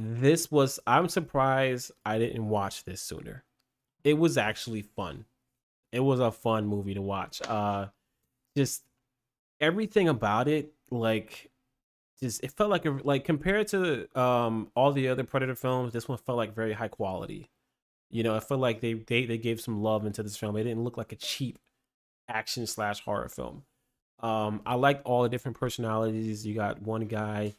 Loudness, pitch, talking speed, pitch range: -29 LUFS, 120 Hz, 180 wpm, 110-135 Hz